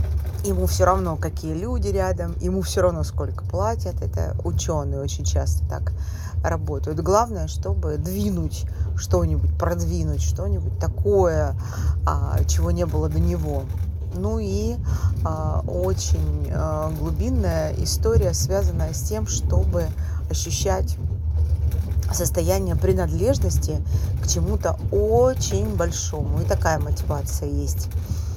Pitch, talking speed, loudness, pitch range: 85 Hz, 105 wpm, -23 LUFS, 80-90 Hz